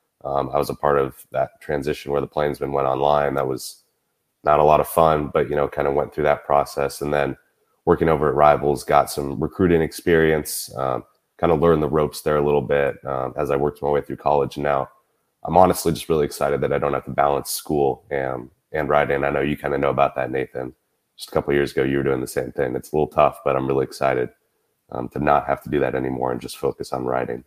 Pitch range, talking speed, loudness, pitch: 65-75 Hz, 255 wpm, -21 LUFS, 70 Hz